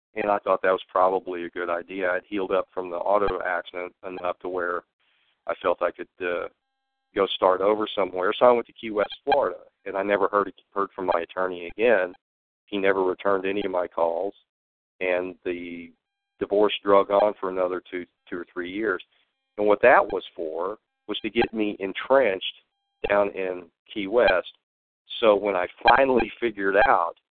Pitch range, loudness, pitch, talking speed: 90-105 Hz, -24 LUFS, 95 Hz, 180 wpm